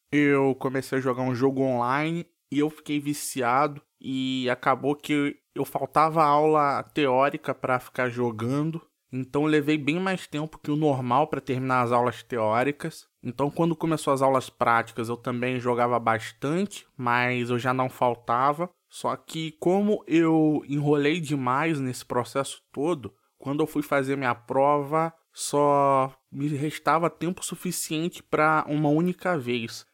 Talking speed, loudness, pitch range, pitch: 150 wpm, -25 LUFS, 125-155 Hz, 145 Hz